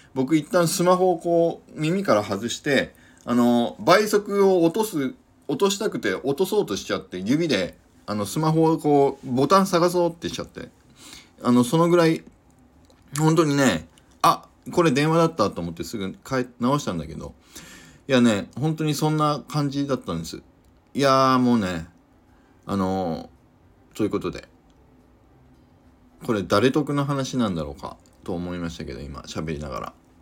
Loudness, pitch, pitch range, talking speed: -22 LUFS, 140 Hz, 105-165 Hz, 300 characters per minute